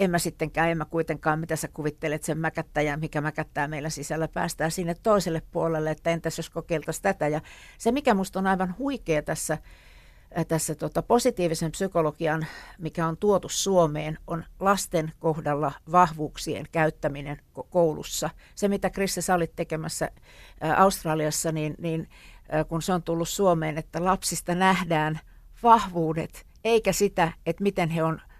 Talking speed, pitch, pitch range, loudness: 150 wpm, 165 Hz, 155-180 Hz, -26 LUFS